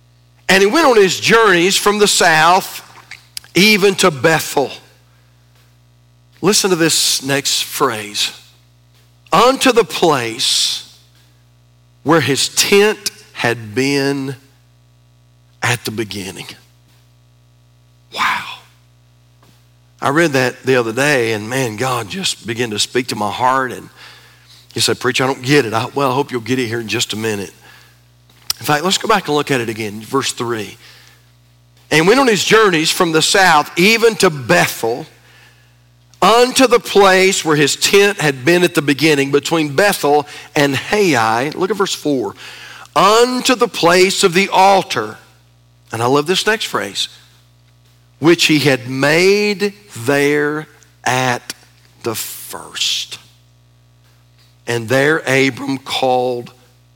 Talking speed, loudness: 140 wpm, -14 LUFS